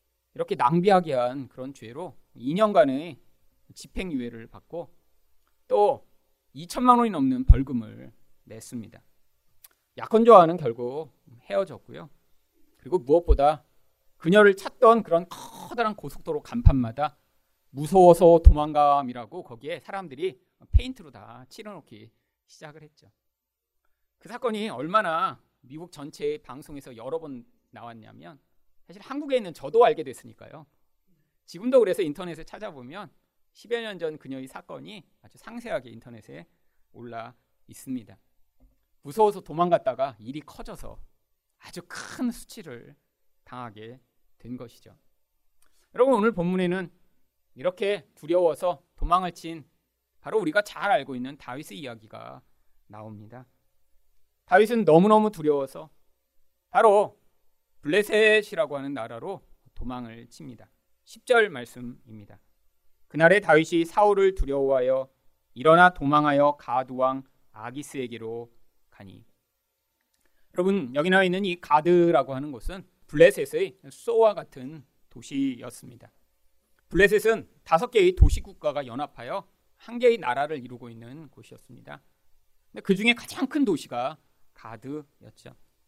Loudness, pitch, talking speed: -23 LUFS, 145 Hz, 280 characters per minute